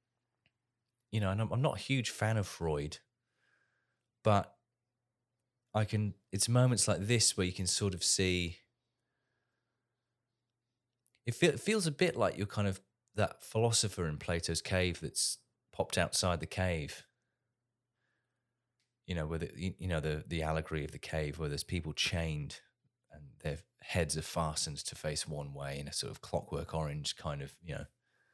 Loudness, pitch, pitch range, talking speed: -34 LUFS, 100 Hz, 80-120 Hz, 165 wpm